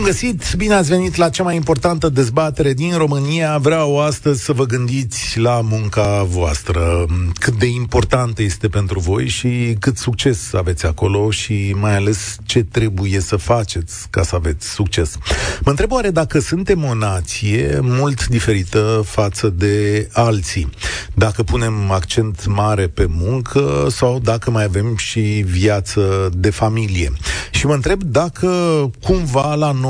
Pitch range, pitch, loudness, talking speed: 100-140 Hz, 110 Hz, -17 LUFS, 150 wpm